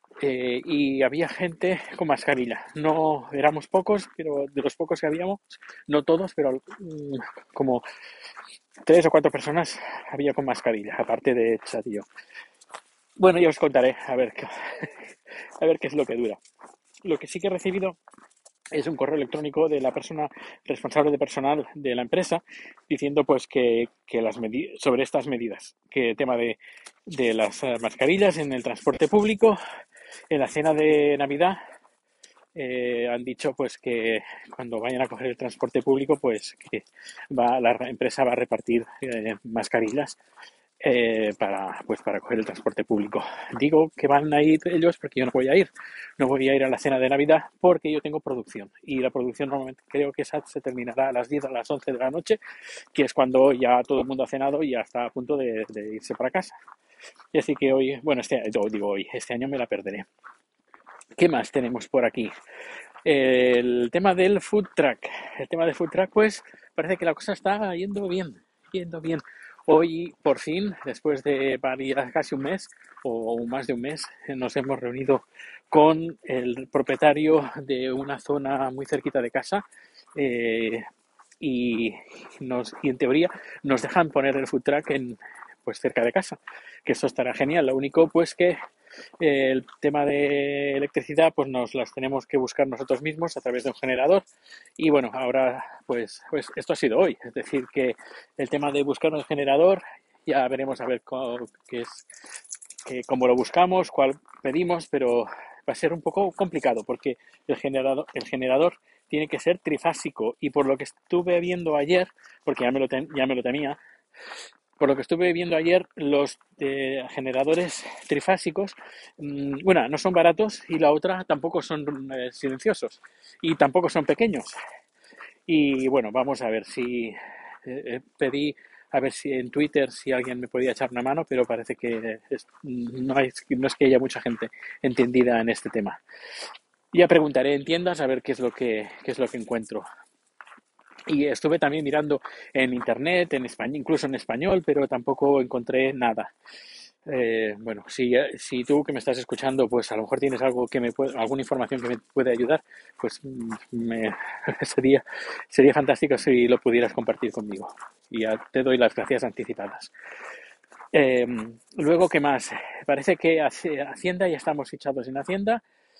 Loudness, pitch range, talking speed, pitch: -25 LUFS, 130-160 Hz, 180 wpm, 140 Hz